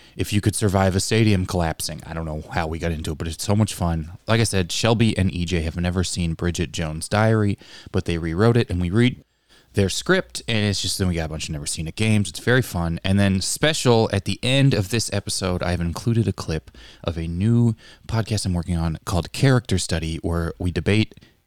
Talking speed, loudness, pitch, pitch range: 230 wpm, -22 LUFS, 95 Hz, 85-110 Hz